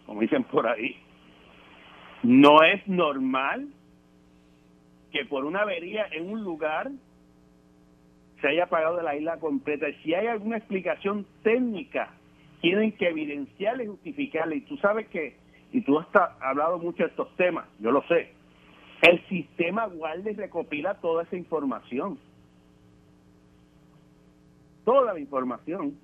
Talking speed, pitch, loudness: 135 wpm, 155 Hz, -26 LUFS